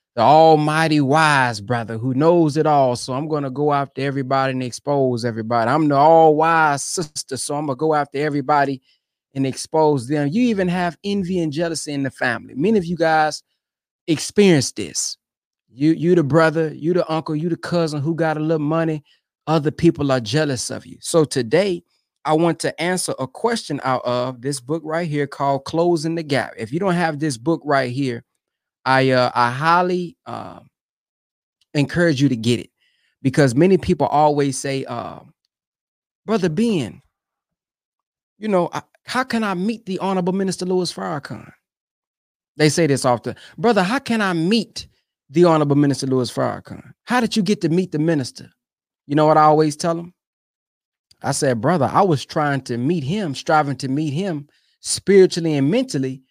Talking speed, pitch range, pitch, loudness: 180 wpm, 140-170 Hz, 155 Hz, -19 LUFS